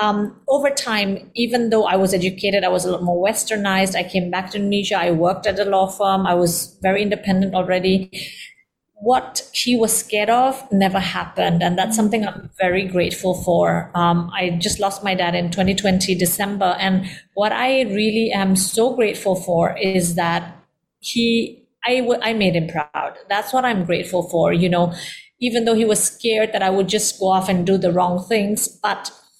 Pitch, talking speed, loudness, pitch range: 195 Hz, 190 wpm, -19 LUFS, 180-215 Hz